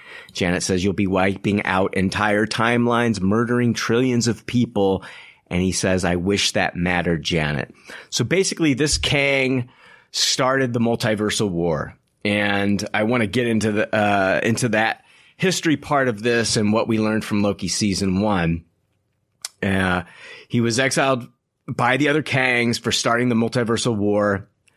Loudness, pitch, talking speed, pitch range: -20 LUFS, 110 Hz, 155 wpm, 100-120 Hz